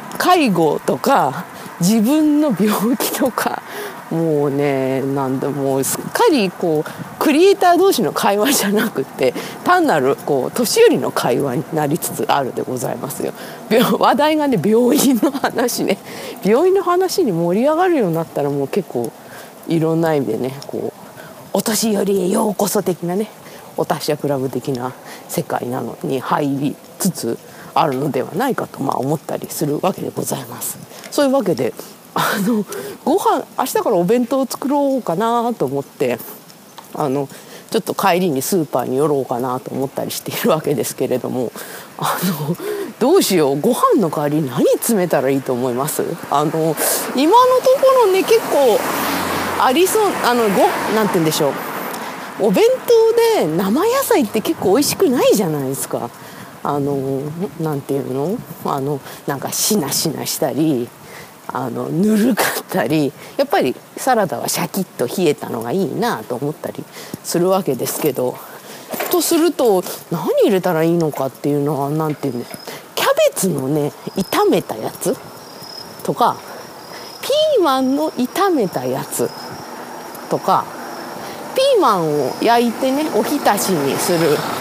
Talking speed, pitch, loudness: 300 characters per minute, 205 Hz, -17 LUFS